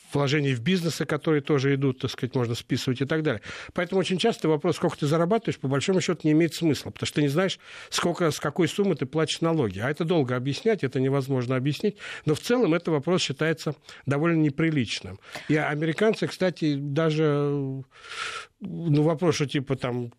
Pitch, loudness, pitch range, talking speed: 155 Hz, -25 LUFS, 140-170 Hz, 185 wpm